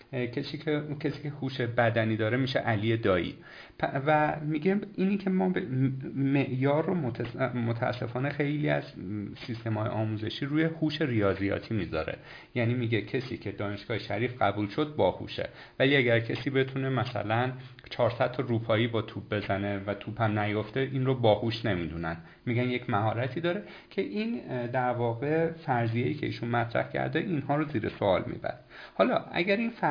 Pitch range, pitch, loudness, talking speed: 110-145 Hz, 125 Hz, -30 LUFS, 155 wpm